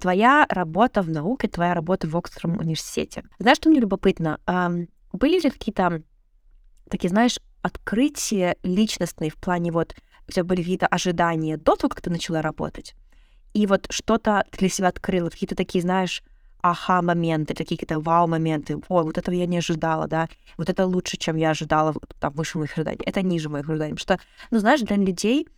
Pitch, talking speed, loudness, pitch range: 180 Hz, 180 wpm, -23 LUFS, 165-200 Hz